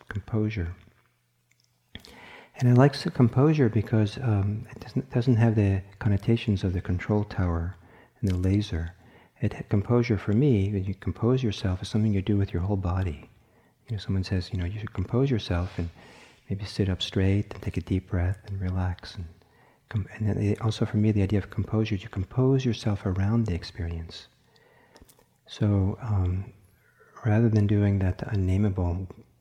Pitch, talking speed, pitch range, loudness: 105 Hz, 170 wpm, 95-110 Hz, -27 LUFS